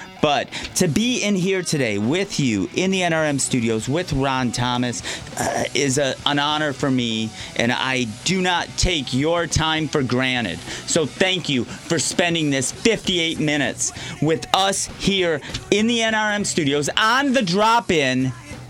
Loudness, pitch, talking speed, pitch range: -20 LUFS, 150 Hz, 160 wpm, 130-185 Hz